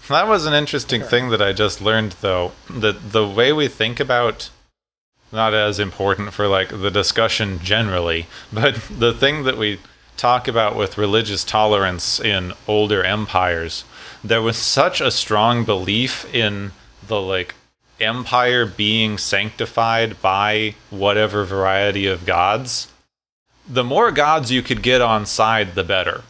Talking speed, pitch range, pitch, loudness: 145 wpm, 100-115 Hz, 110 Hz, -18 LUFS